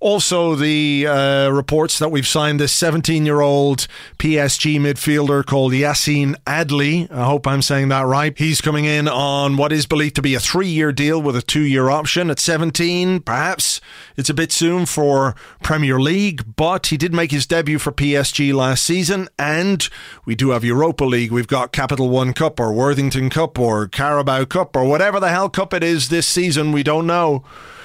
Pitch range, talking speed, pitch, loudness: 140-165 Hz, 190 wpm, 150 Hz, -17 LUFS